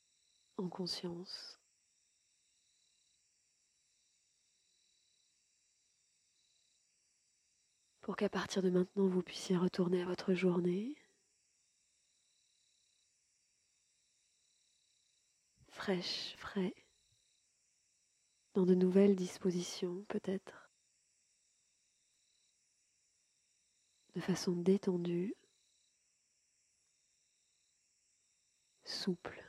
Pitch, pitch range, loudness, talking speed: 185 Hz, 180-195 Hz, -37 LUFS, 50 wpm